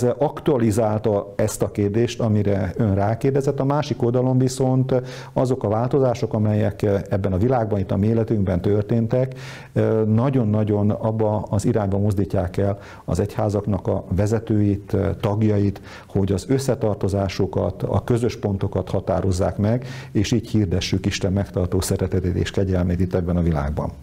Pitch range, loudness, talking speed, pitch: 100-120 Hz, -21 LUFS, 135 wpm, 105 Hz